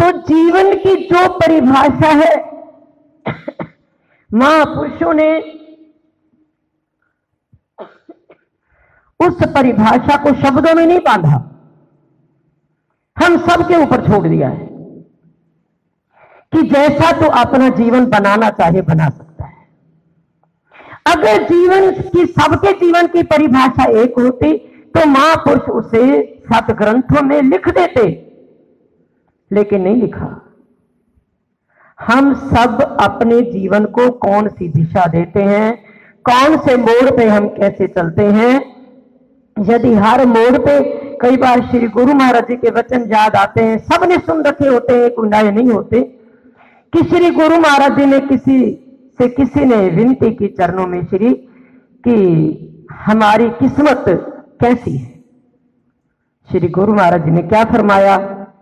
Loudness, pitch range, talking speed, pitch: -11 LUFS, 210-290 Hz, 120 wpm, 245 Hz